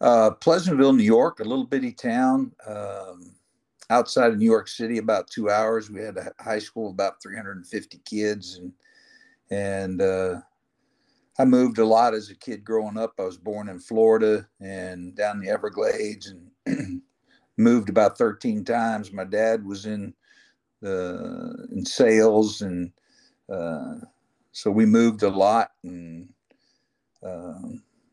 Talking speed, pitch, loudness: 150 wpm, 110 Hz, -23 LUFS